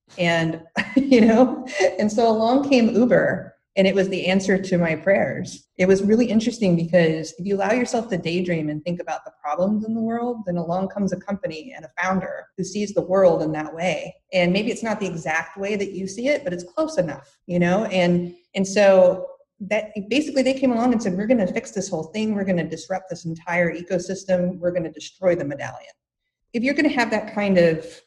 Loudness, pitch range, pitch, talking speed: -21 LUFS, 175-225 Hz, 190 Hz, 225 wpm